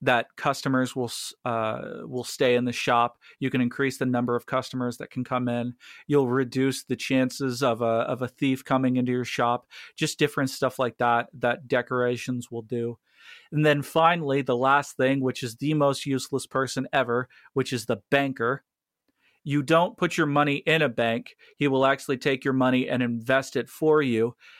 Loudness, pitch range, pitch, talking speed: -25 LUFS, 120-140 Hz, 130 Hz, 190 wpm